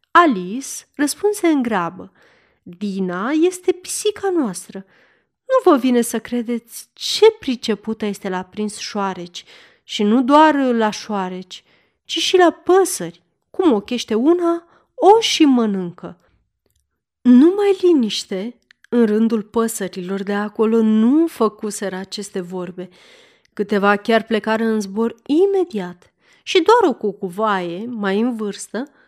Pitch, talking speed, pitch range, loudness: 225 Hz, 120 wpm, 200-320 Hz, -18 LUFS